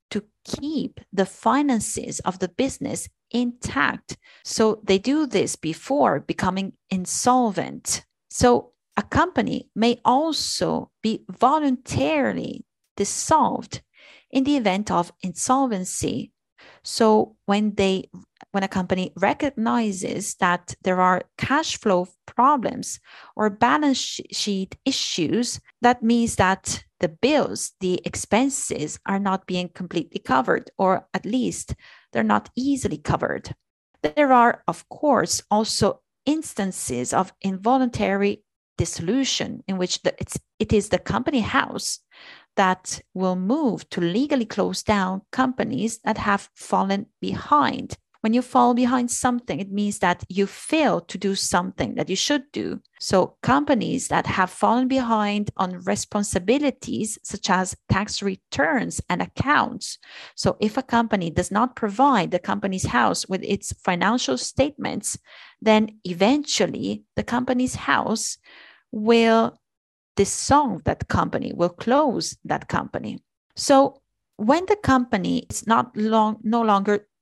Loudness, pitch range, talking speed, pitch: -23 LUFS, 190-250 Hz, 125 wpm, 215 Hz